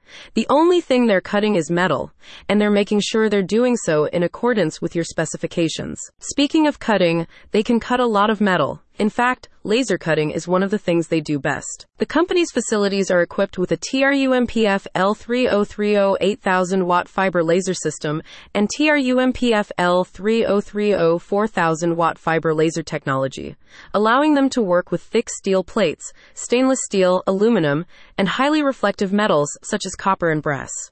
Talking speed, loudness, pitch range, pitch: 160 wpm, -19 LUFS, 175-225 Hz, 200 Hz